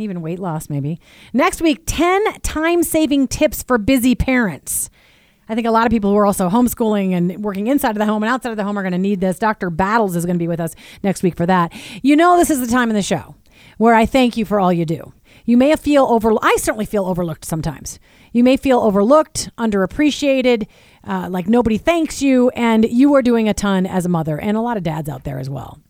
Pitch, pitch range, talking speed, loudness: 220 Hz, 185-255 Hz, 245 wpm, -17 LUFS